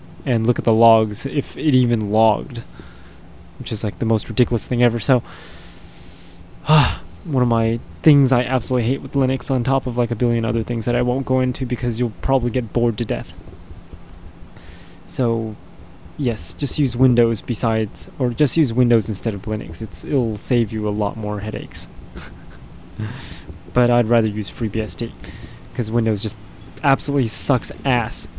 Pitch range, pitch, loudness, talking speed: 90-125 Hz, 115 Hz, -19 LUFS, 170 wpm